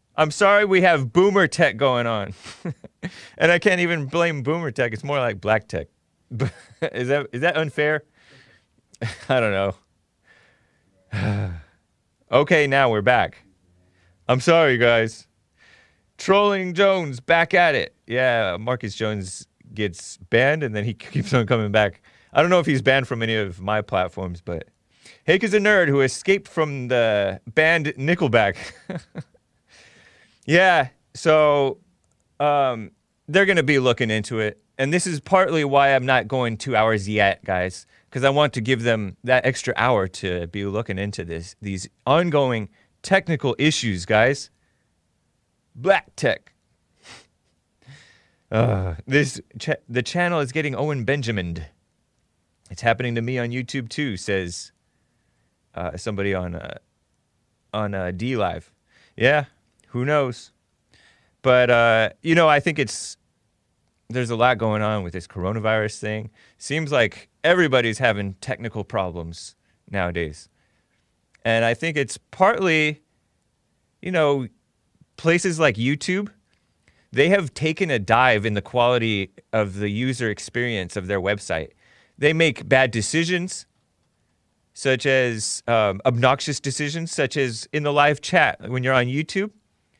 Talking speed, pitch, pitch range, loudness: 140 wpm, 120 Hz, 105-145 Hz, -21 LUFS